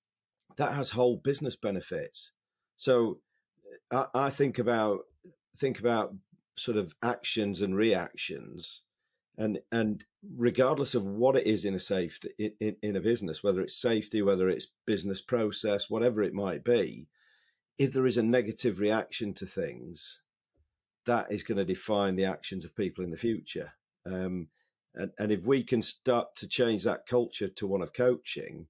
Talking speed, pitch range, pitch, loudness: 165 wpm, 100-125 Hz, 110 Hz, -31 LUFS